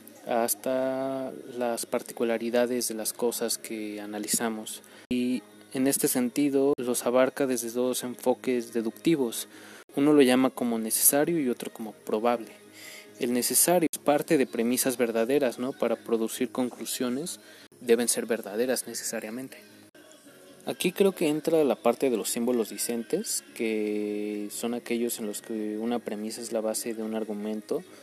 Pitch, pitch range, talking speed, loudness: 120 Hz, 110-130 Hz, 140 wpm, -27 LUFS